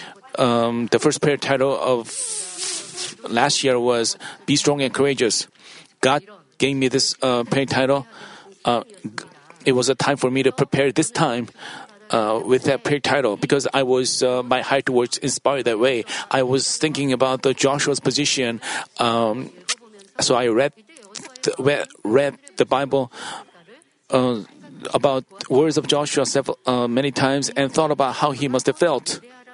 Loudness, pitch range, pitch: -20 LUFS, 130-140 Hz, 135 Hz